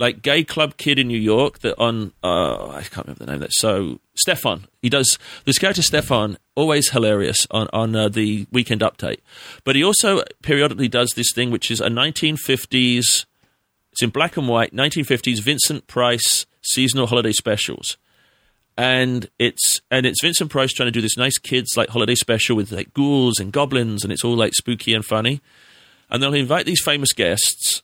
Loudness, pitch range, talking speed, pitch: -18 LUFS, 115-140 Hz, 190 wpm, 125 Hz